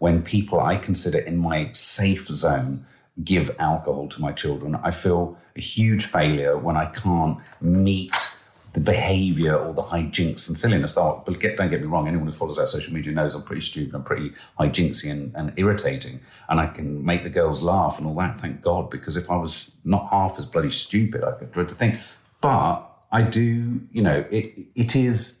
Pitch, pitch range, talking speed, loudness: 85 Hz, 80-105 Hz, 200 wpm, -23 LUFS